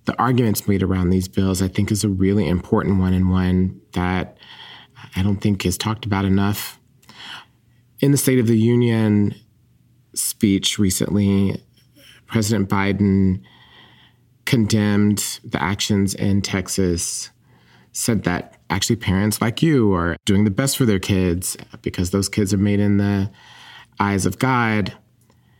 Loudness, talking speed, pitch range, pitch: -20 LUFS, 145 wpm, 95-115 Hz, 100 Hz